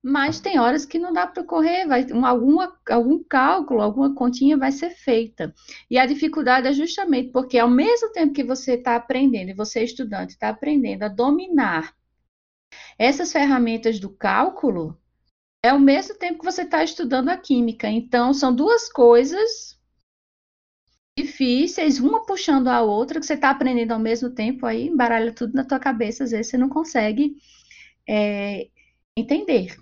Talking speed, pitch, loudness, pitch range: 165 wpm, 265 Hz, -20 LUFS, 235-305 Hz